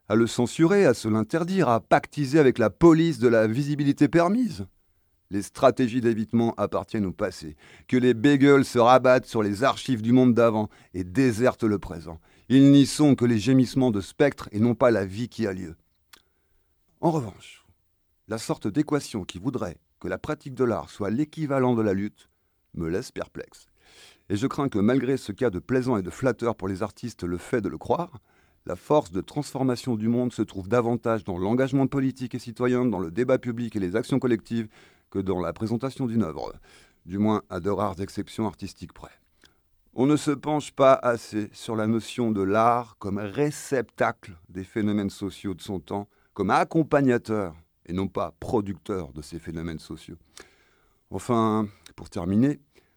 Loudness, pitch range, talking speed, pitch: -24 LUFS, 95-130 Hz, 180 wpm, 115 Hz